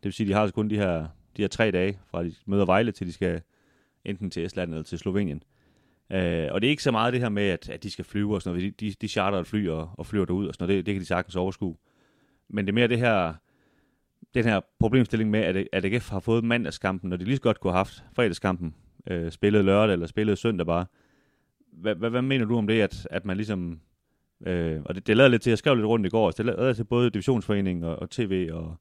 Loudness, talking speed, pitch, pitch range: -26 LUFS, 260 wpm, 100 Hz, 90-110 Hz